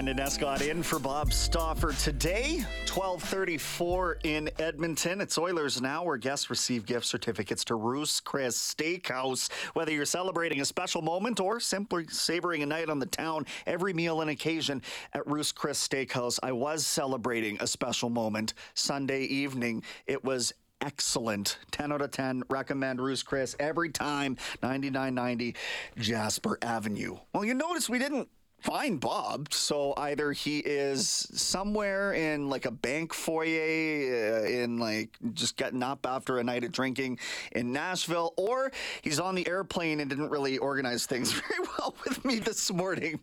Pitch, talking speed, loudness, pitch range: 145 Hz, 155 wpm, -31 LUFS, 130-170 Hz